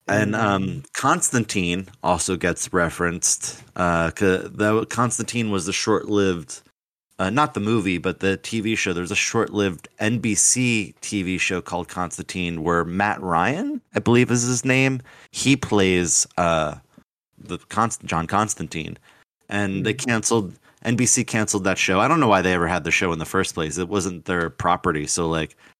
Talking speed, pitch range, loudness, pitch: 160 wpm, 90-115 Hz, -21 LUFS, 100 Hz